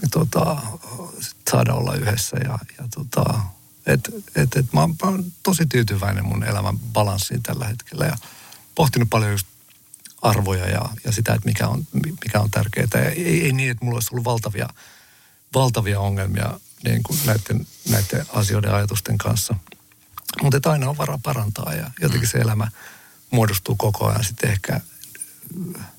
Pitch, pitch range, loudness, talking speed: 120 Hz, 105-140 Hz, -22 LUFS, 155 wpm